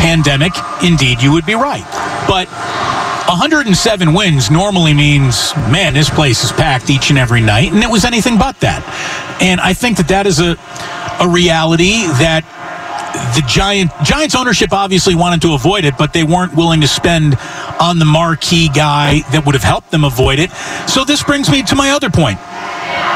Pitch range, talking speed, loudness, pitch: 150-185 Hz, 180 wpm, -11 LUFS, 165 Hz